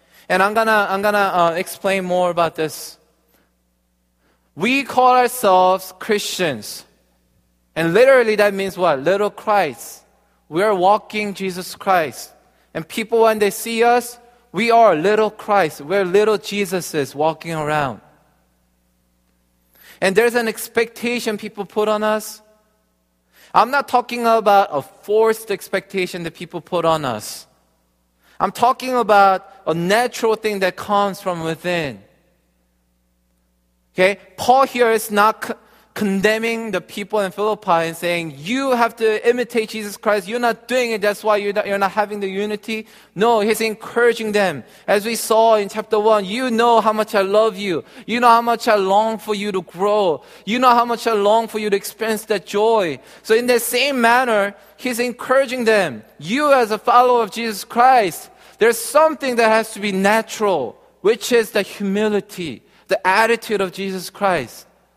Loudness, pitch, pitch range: -18 LUFS, 210 Hz, 185-225 Hz